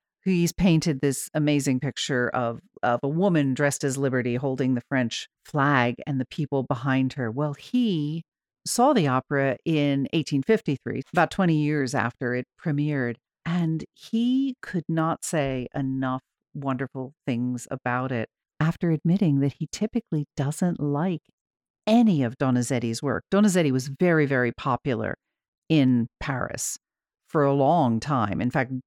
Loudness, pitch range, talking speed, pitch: -25 LUFS, 130-160 Hz, 140 wpm, 140 Hz